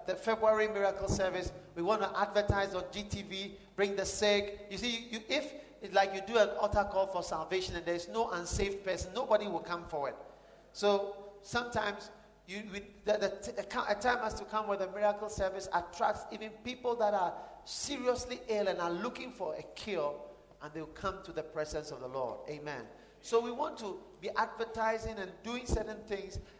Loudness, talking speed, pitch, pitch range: -35 LUFS, 190 wpm, 200 Hz, 185-220 Hz